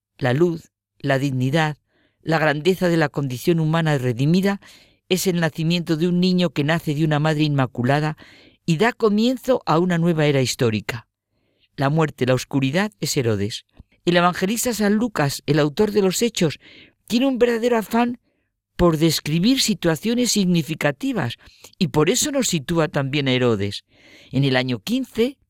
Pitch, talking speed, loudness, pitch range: 160 Hz, 155 wpm, -20 LUFS, 135-195 Hz